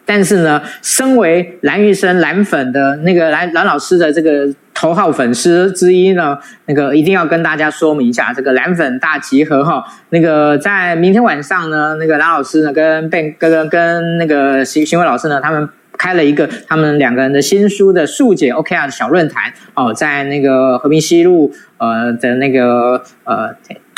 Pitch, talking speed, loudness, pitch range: 155 Hz, 280 characters per minute, -12 LUFS, 140-175 Hz